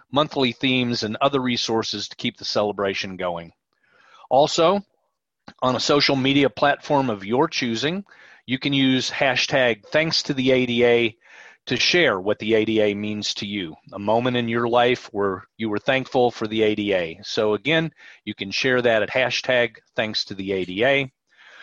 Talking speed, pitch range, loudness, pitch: 165 wpm, 105-135 Hz, -21 LUFS, 120 Hz